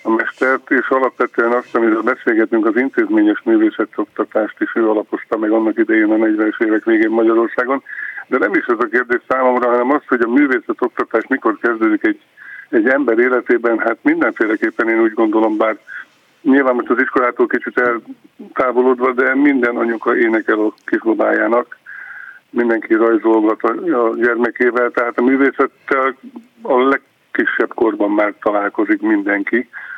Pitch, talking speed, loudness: 135 Hz, 145 wpm, -15 LUFS